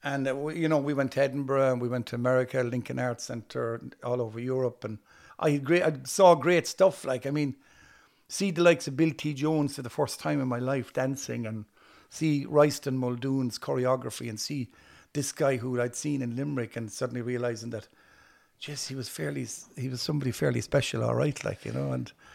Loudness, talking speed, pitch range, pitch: -29 LUFS, 205 wpm, 120-145 Hz, 130 Hz